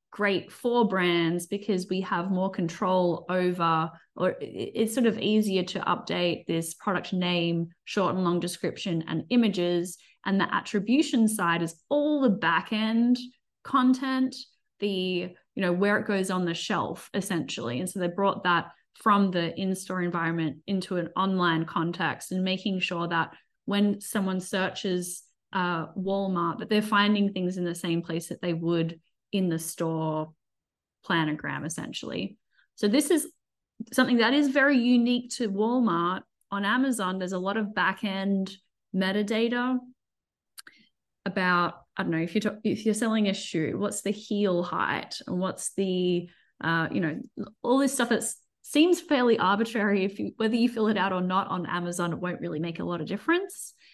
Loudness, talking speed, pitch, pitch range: -27 LUFS, 165 wpm, 190 Hz, 175-220 Hz